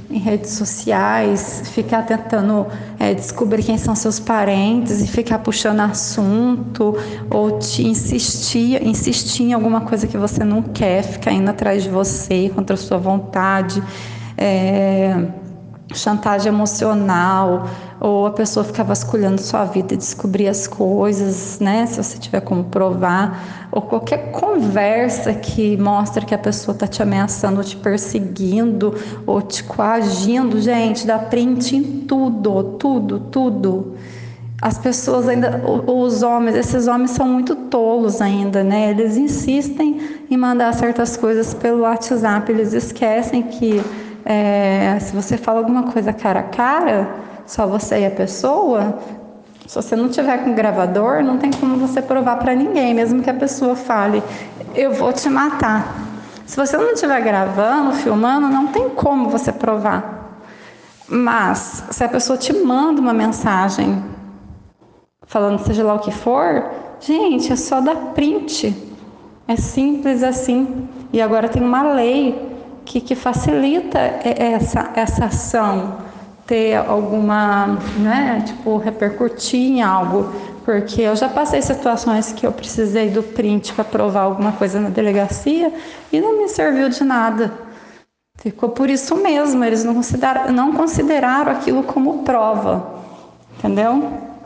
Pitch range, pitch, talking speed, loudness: 205-250 Hz, 225 Hz, 145 wpm, -17 LUFS